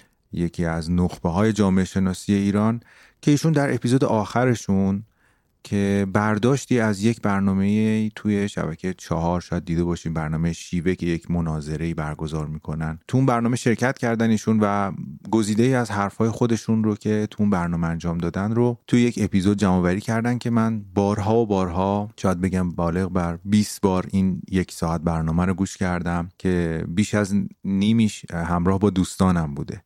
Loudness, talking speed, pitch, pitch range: -22 LUFS, 165 wpm, 100 Hz, 85-110 Hz